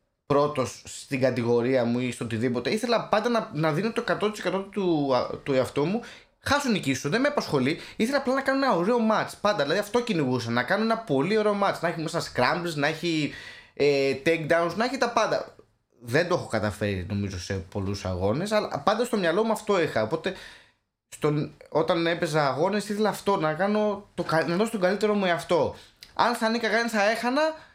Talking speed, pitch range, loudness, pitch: 195 wpm, 140-220 Hz, -26 LUFS, 175 Hz